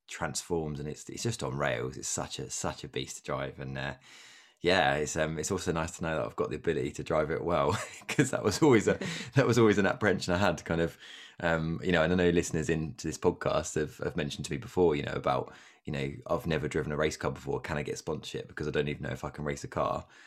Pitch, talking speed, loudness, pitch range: 80 Hz, 270 wpm, -31 LUFS, 75-90 Hz